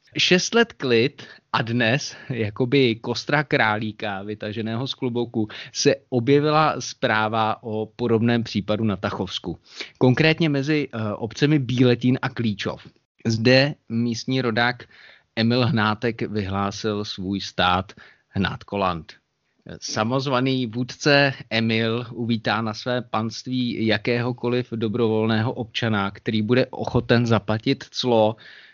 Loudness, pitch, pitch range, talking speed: -22 LUFS, 115 Hz, 110-130 Hz, 100 wpm